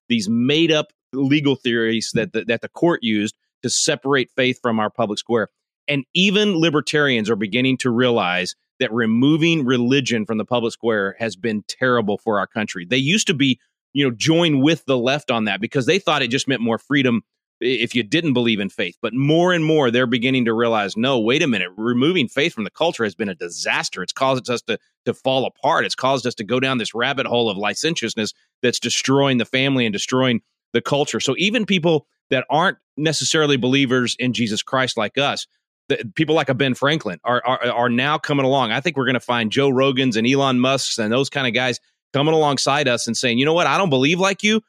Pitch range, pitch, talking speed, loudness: 120-145 Hz, 130 Hz, 220 wpm, -19 LUFS